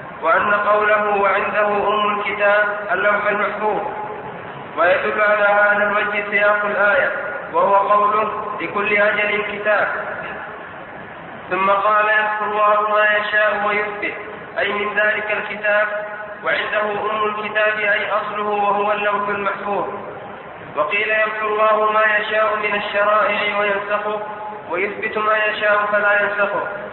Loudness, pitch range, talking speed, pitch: -17 LUFS, 205-210 Hz, 110 wpm, 210 Hz